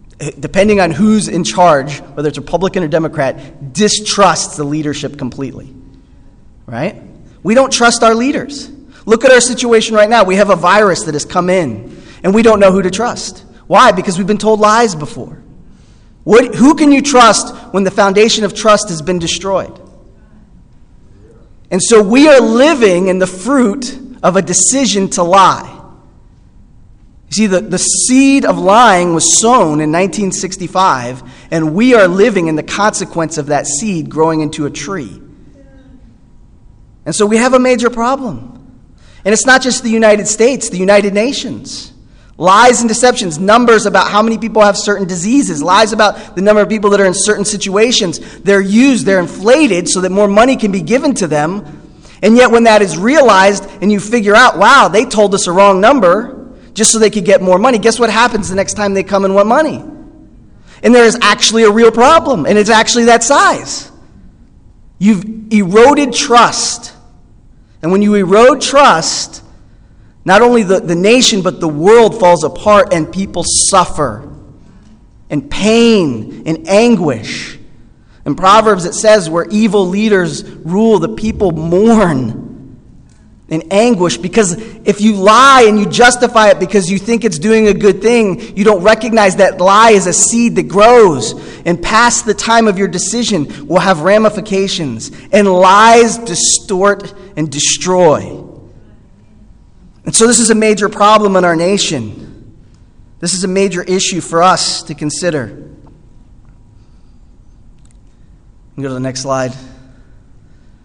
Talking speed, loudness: 160 wpm, -9 LUFS